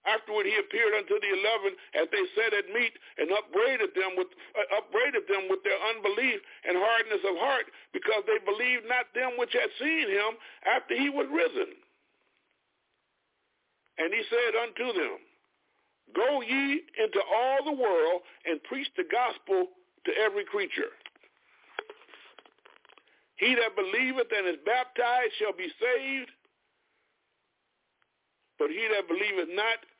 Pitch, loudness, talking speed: 390 Hz, -28 LUFS, 140 wpm